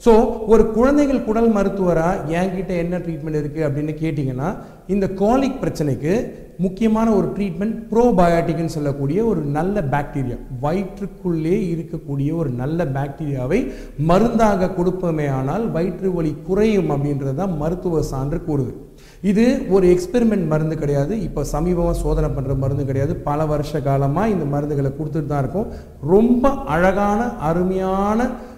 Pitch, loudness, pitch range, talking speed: 175 Hz, -20 LUFS, 150-200 Hz, 125 wpm